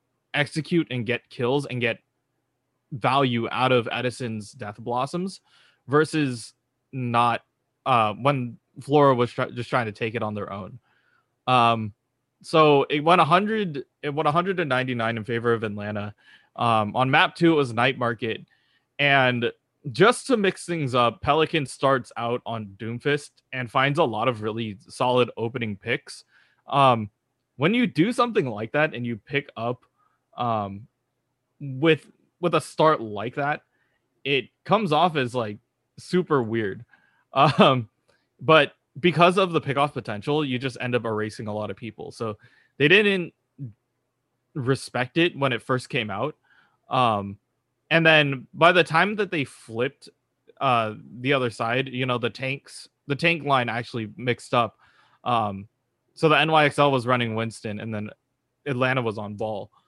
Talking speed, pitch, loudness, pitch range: 155 wpm, 125 Hz, -23 LUFS, 115-145 Hz